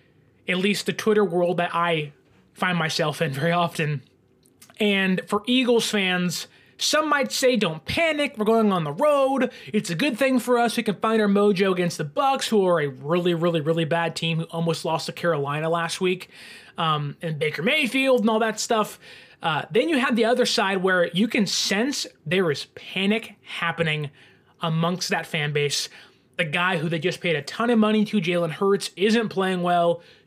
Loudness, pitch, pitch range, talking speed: -23 LUFS, 185 Hz, 165-225 Hz, 195 wpm